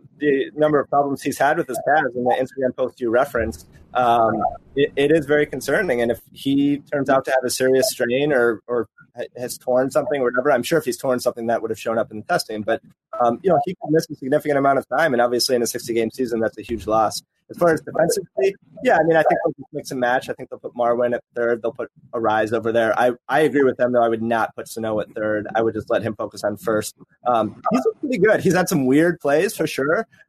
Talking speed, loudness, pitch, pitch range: 265 wpm, -20 LUFS, 130 Hz, 115-145 Hz